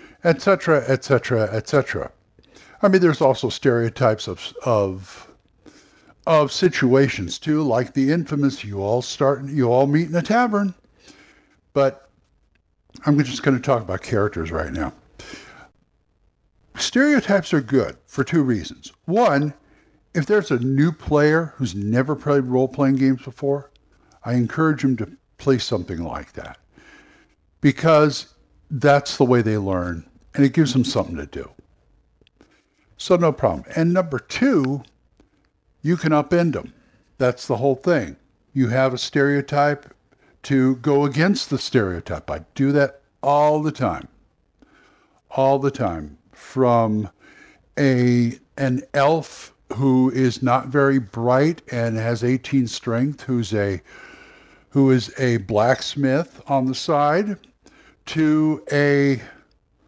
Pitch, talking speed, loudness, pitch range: 135 Hz, 130 wpm, -20 LUFS, 120-145 Hz